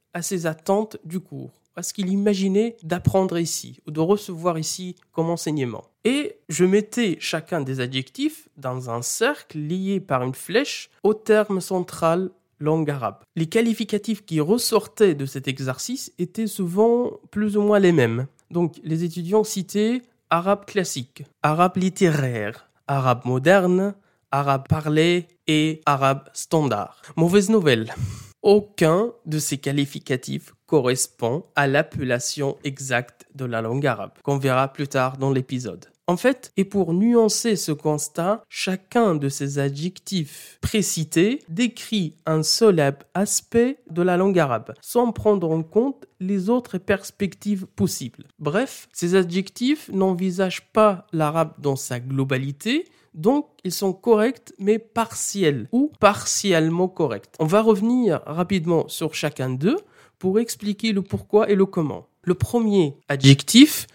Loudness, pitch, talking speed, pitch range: -22 LUFS, 175 Hz, 140 wpm, 145-210 Hz